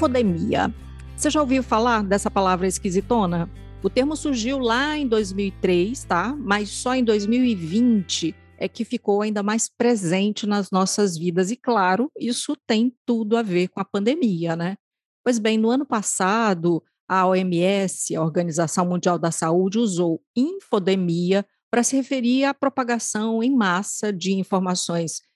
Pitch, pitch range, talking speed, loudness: 210 Hz, 185-240 Hz, 145 wpm, -22 LUFS